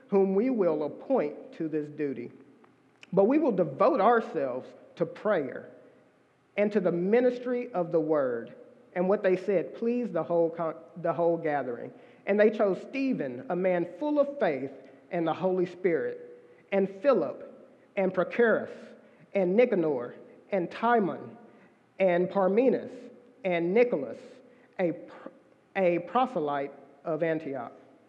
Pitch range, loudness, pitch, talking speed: 170-245 Hz, -28 LUFS, 190 Hz, 135 wpm